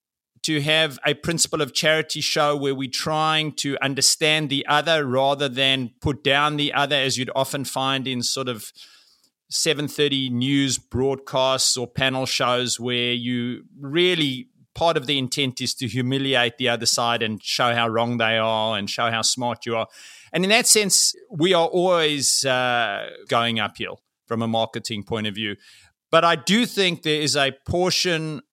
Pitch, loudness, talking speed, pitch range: 135 Hz, -21 LUFS, 170 wpm, 120-150 Hz